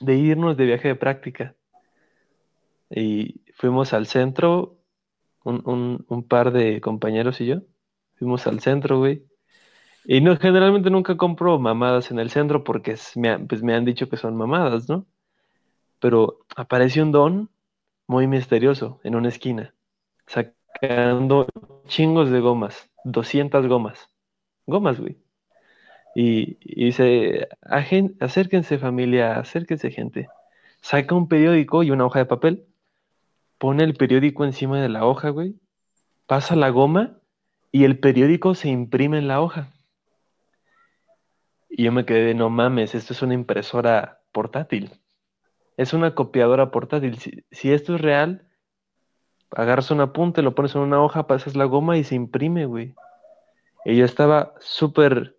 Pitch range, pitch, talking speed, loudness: 125-165 Hz, 140 Hz, 145 wpm, -20 LUFS